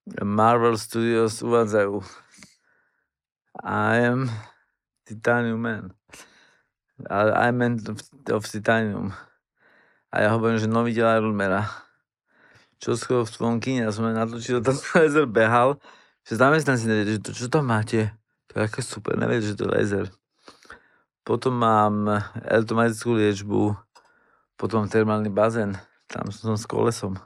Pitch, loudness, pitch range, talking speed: 115 Hz, -23 LUFS, 105-120 Hz, 130 wpm